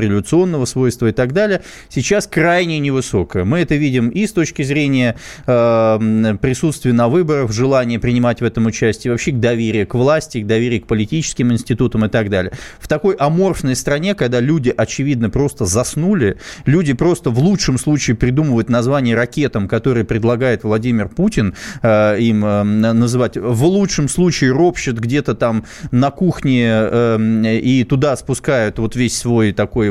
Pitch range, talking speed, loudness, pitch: 115-150 Hz, 155 wpm, -15 LUFS, 125 Hz